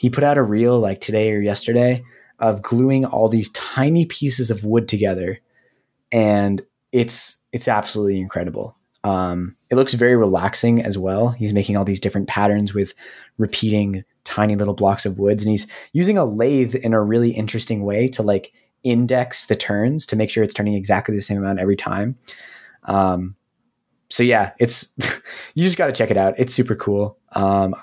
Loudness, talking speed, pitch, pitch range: -19 LUFS, 180 wpm, 110 Hz, 100-125 Hz